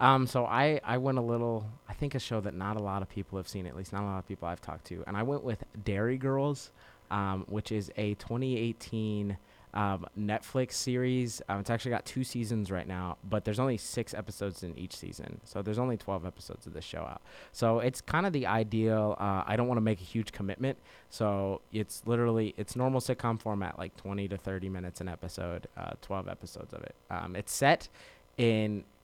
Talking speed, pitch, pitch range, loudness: 215 wpm, 105 Hz, 100-120 Hz, -33 LUFS